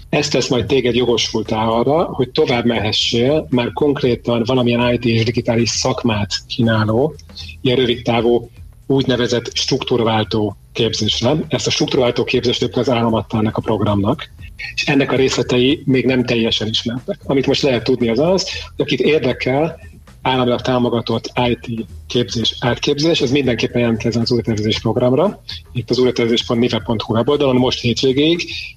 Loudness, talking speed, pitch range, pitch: -16 LUFS, 135 wpm, 115-130 Hz, 120 Hz